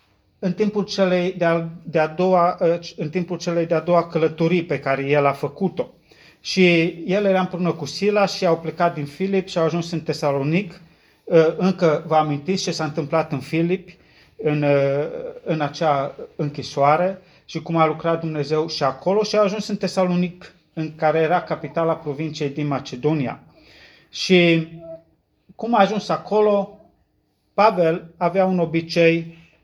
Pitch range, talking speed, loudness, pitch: 155-185 Hz, 150 wpm, -21 LUFS, 165 Hz